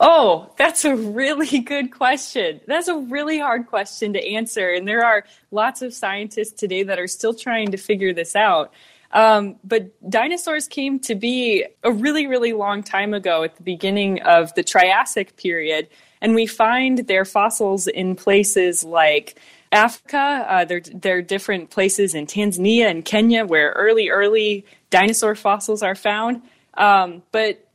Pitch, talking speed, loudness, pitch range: 215 Hz, 160 wpm, -18 LUFS, 195-240 Hz